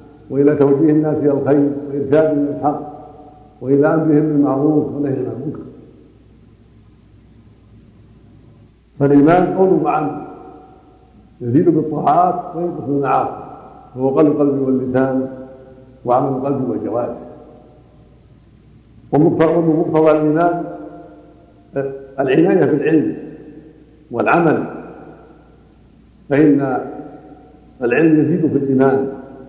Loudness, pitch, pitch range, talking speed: -16 LUFS, 140 Hz, 130-150 Hz, 75 wpm